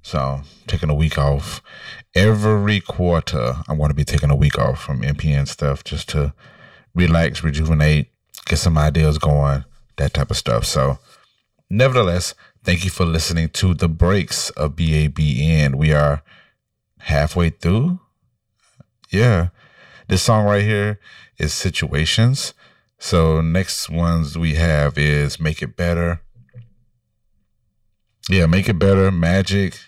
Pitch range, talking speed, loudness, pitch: 75-100 Hz, 135 wpm, -18 LUFS, 85 Hz